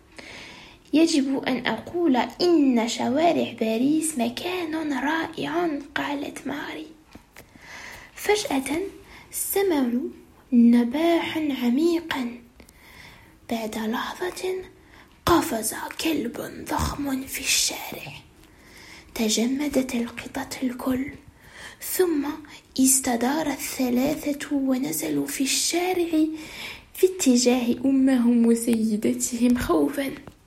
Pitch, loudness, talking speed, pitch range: 280 Hz, -24 LUFS, 70 wpm, 245-315 Hz